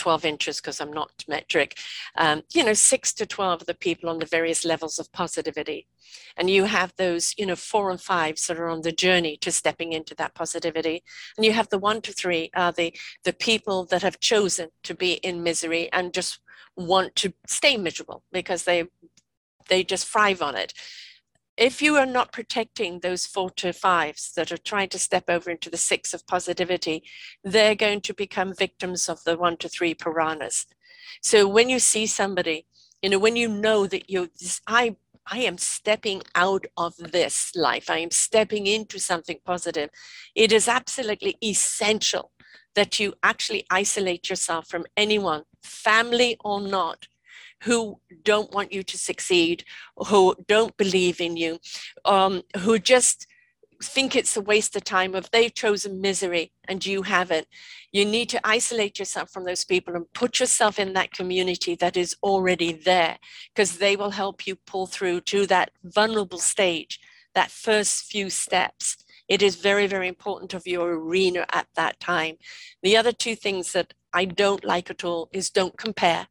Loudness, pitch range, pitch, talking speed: -23 LUFS, 175-215 Hz, 190 Hz, 180 wpm